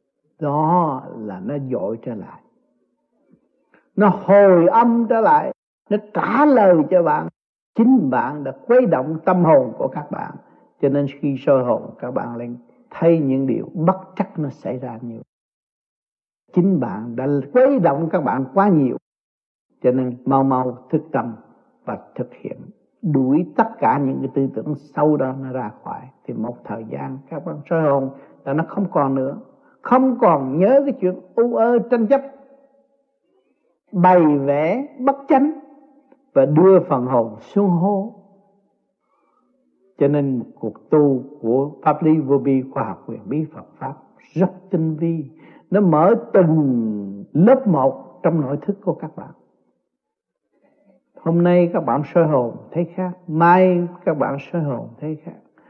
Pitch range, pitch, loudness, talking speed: 140-205 Hz, 170 Hz, -18 LUFS, 165 wpm